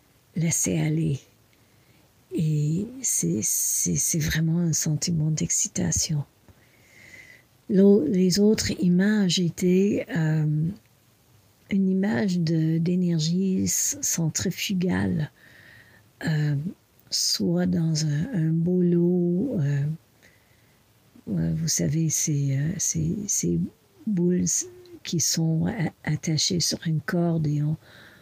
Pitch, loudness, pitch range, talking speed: 165 Hz, -24 LUFS, 150-180 Hz, 85 wpm